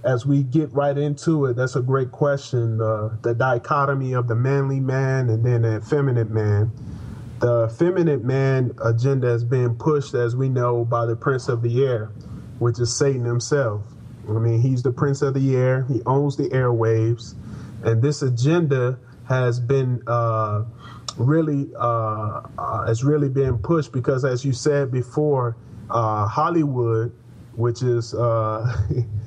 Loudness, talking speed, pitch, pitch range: -21 LUFS, 155 wpm, 125 Hz, 115-135 Hz